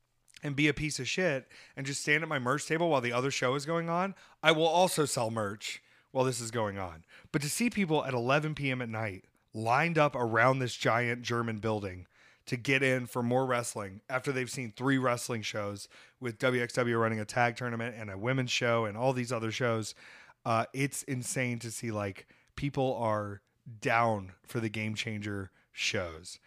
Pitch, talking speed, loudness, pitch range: 125 Hz, 195 wpm, -31 LUFS, 110-135 Hz